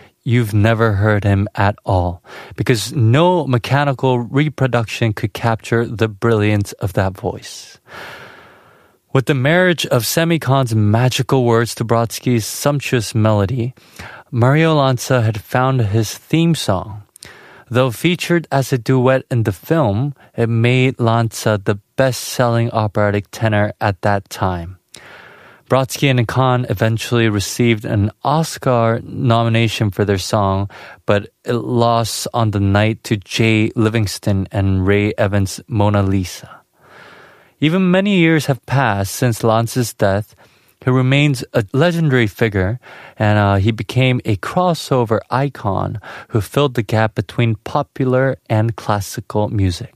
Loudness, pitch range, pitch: -16 LUFS, 105-130 Hz, 115 Hz